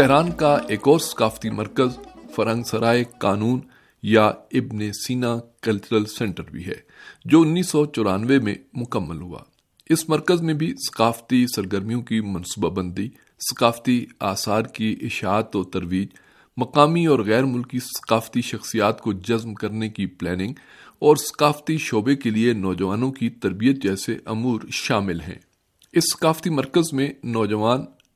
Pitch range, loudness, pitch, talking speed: 105-135 Hz, -22 LUFS, 115 Hz, 140 wpm